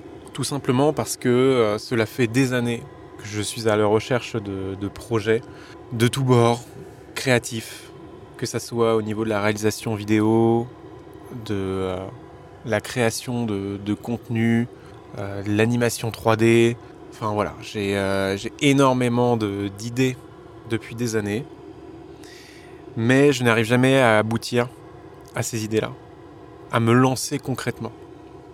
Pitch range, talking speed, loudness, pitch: 110-130 Hz, 140 wpm, -22 LUFS, 115 Hz